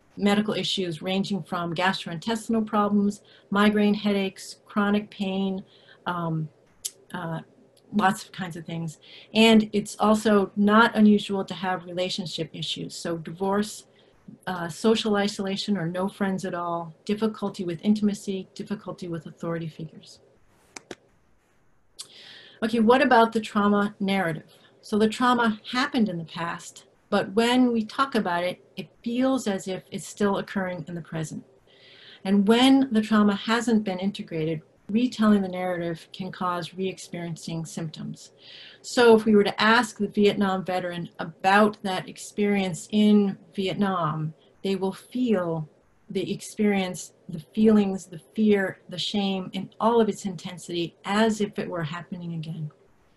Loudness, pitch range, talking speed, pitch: -25 LUFS, 175-210 Hz, 140 wpm, 195 Hz